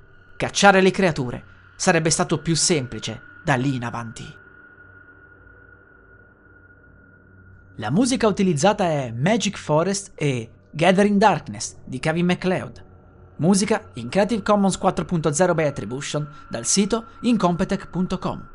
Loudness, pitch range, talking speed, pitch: -21 LUFS, 120-200 Hz, 105 wpm, 170 Hz